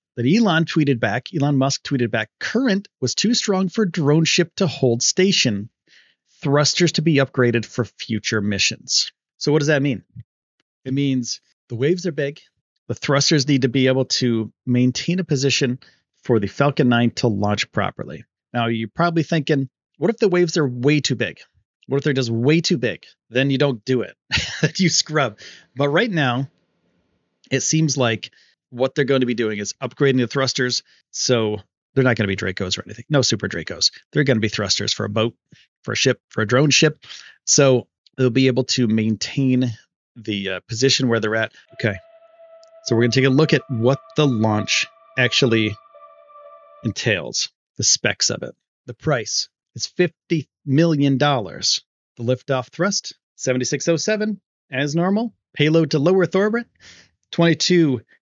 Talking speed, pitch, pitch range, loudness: 175 wpm, 135 Hz, 120-160 Hz, -20 LUFS